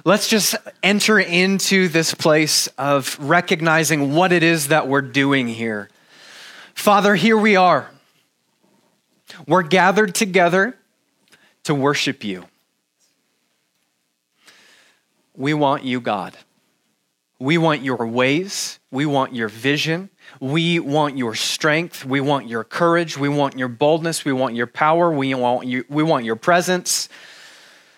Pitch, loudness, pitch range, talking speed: 155 Hz, -18 LUFS, 135-180 Hz, 130 wpm